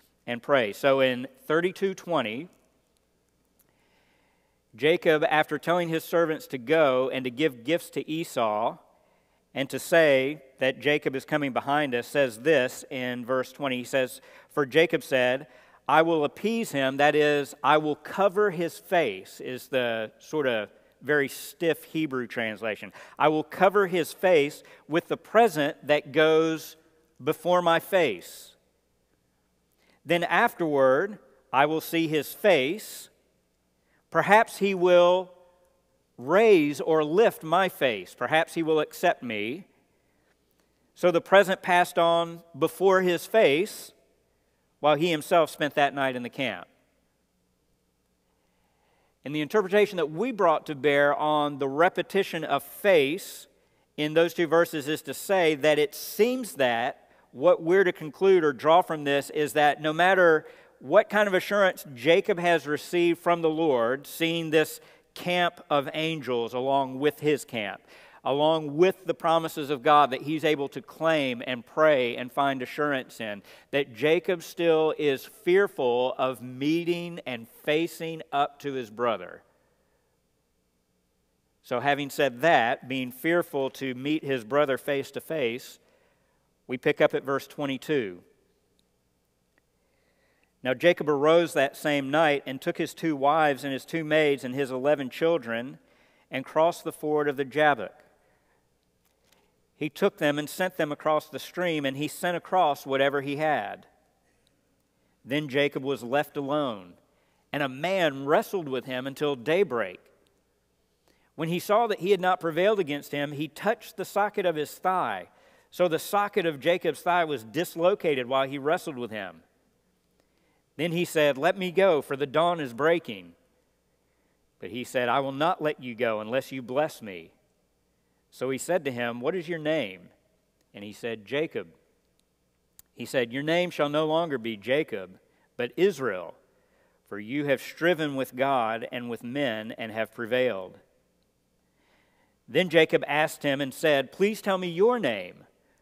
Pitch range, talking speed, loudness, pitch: 130-170 Hz, 150 wpm, -26 LUFS, 150 Hz